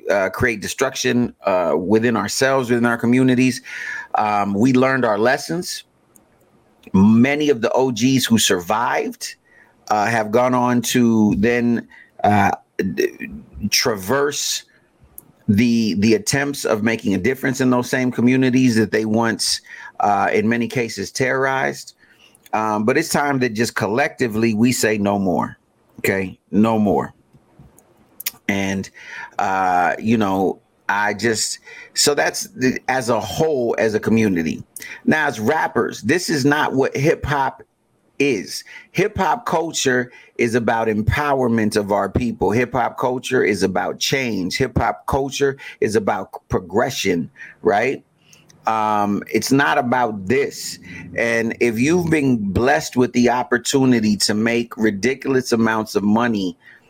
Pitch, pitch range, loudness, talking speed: 120 Hz, 110-130 Hz, -19 LUFS, 135 wpm